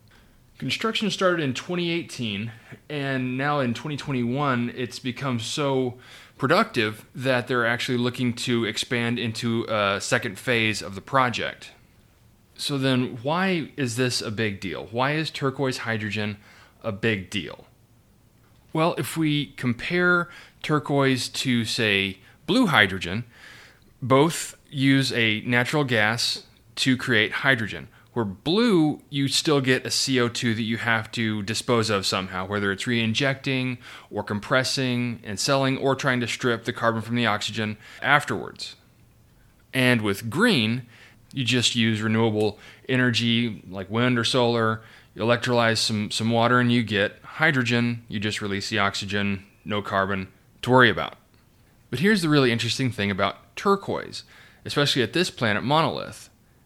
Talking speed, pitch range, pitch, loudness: 140 wpm, 110-130 Hz, 120 Hz, -24 LUFS